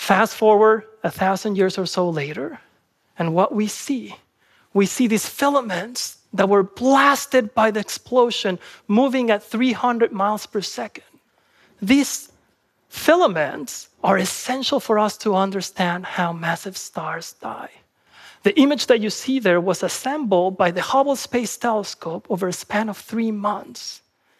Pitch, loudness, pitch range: 215 Hz, -20 LUFS, 190-250 Hz